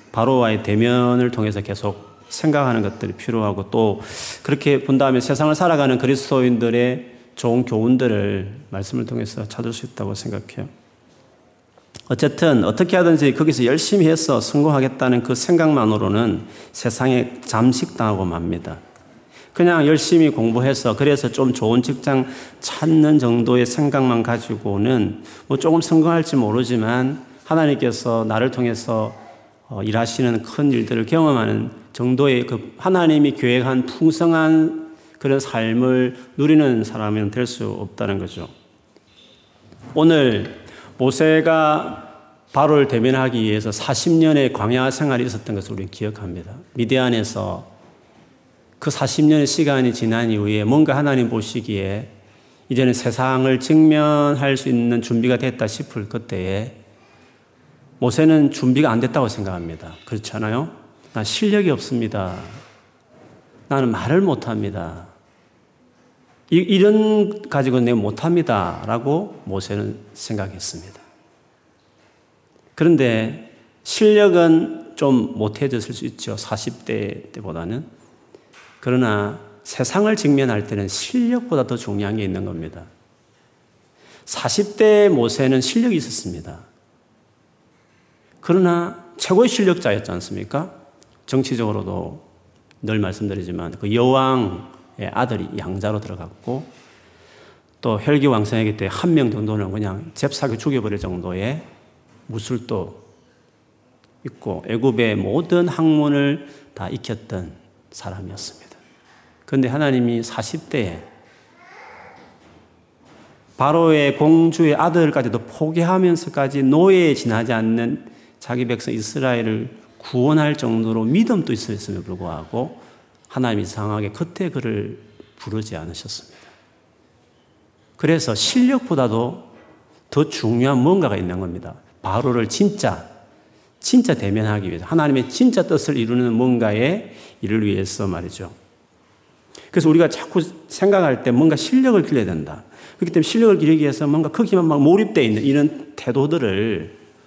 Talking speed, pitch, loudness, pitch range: 275 characters per minute, 125 Hz, -19 LUFS, 110-150 Hz